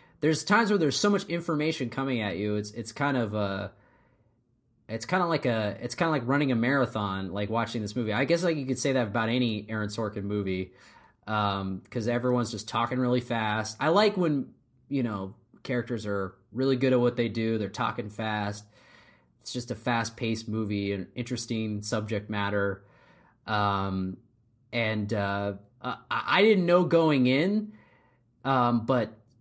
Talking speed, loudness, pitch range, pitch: 175 wpm, -28 LUFS, 105-130 Hz, 120 Hz